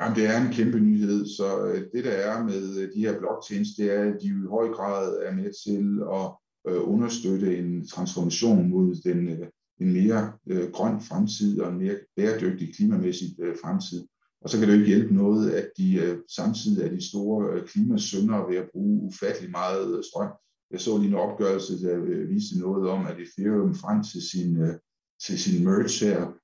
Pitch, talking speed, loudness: 110 Hz, 180 wpm, -26 LUFS